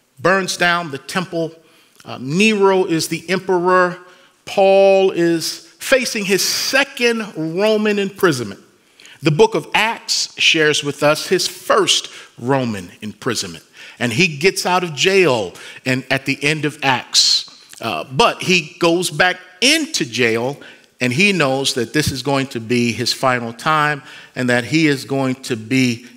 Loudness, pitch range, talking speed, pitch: -16 LUFS, 135-190 Hz, 150 wpm, 160 Hz